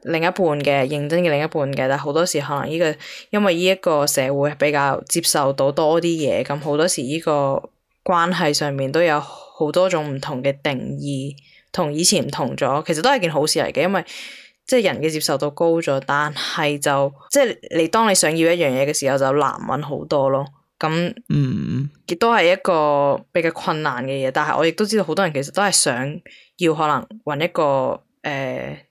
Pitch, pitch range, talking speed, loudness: 150 Hz, 140-170 Hz, 295 characters per minute, -19 LUFS